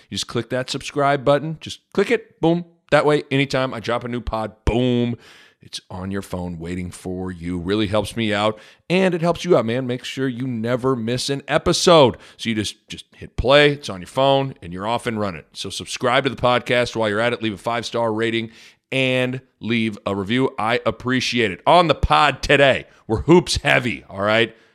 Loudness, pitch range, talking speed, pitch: -20 LUFS, 105-135 Hz, 215 wpm, 120 Hz